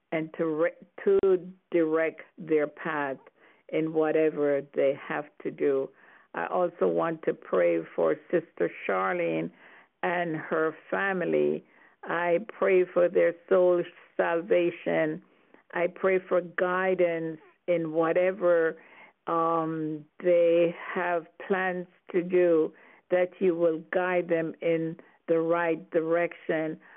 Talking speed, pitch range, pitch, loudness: 115 wpm, 160-180 Hz, 170 Hz, -27 LUFS